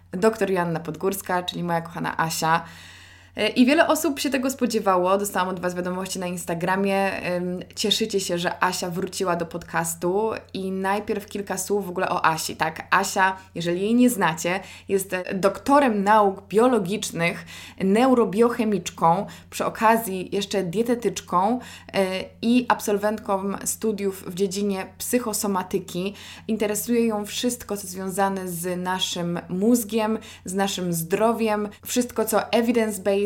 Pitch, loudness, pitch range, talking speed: 195 Hz, -23 LUFS, 180-220 Hz, 125 wpm